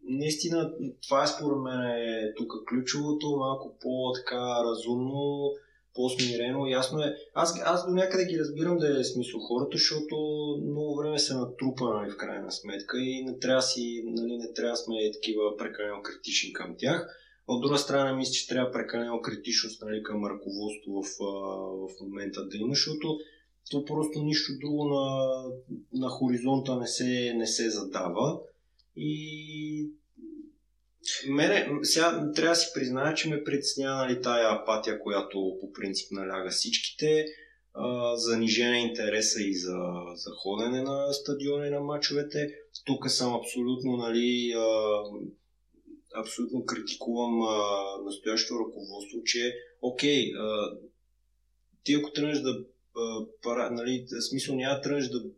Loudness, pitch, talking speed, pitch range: -30 LUFS, 125 Hz, 140 wpm, 115-145 Hz